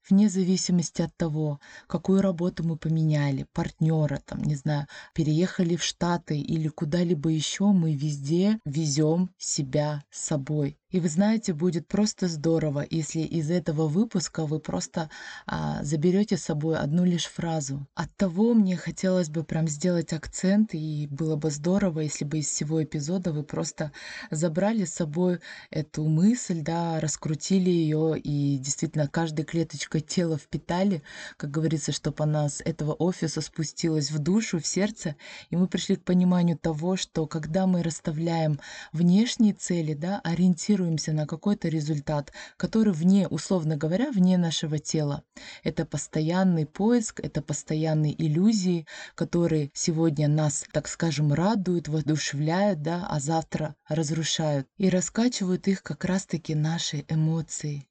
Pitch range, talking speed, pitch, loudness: 155-185 Hz, 140 wpm, 165 Hz, -26 LUFS